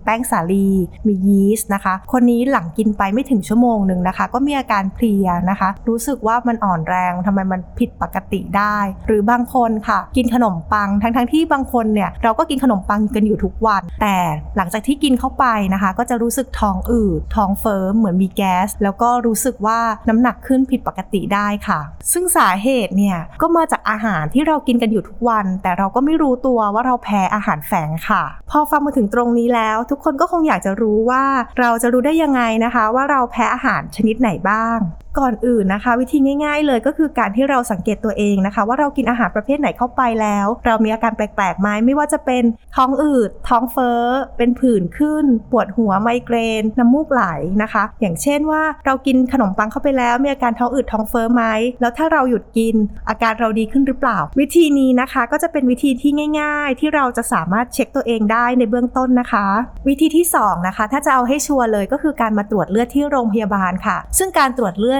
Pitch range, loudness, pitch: 210-260 Hz, -16 LUFS, 235 Hz